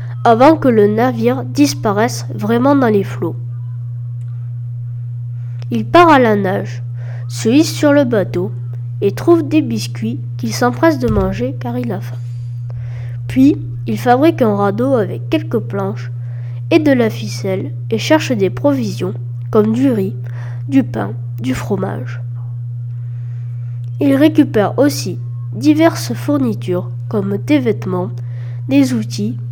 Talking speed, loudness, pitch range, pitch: 130 wpm, -16 LUFS, 120-140 Hz, 120 Hz